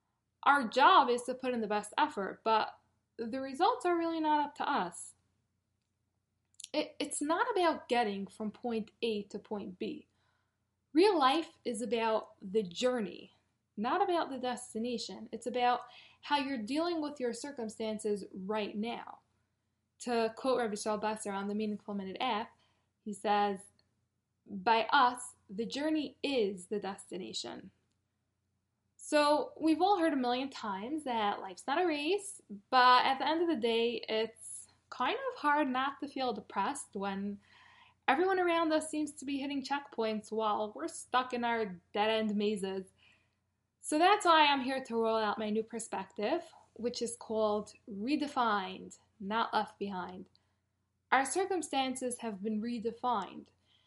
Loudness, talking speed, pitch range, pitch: -33 LUFS, 150 wpm, 205-280 Hz, 230 Hz